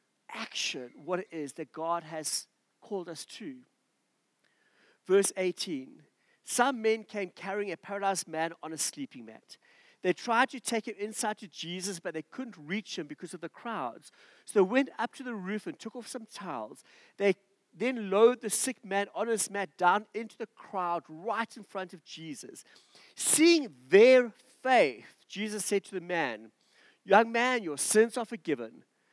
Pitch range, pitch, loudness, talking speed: 180-235 Hz, 205 Hz, -30 LUFS, 175 wpm